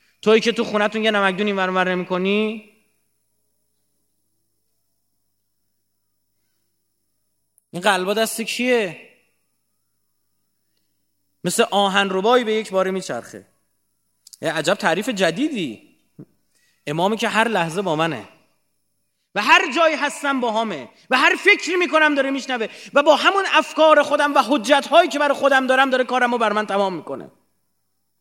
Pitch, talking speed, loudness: 195 Hz, 130 wpm, -18 LUFS